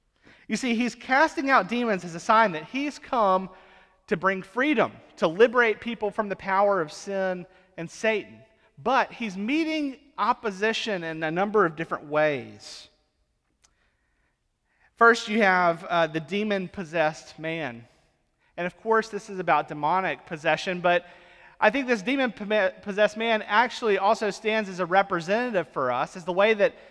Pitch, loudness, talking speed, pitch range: 195 Hz, -25 LUFS, 155 wpm, 175-225 Hz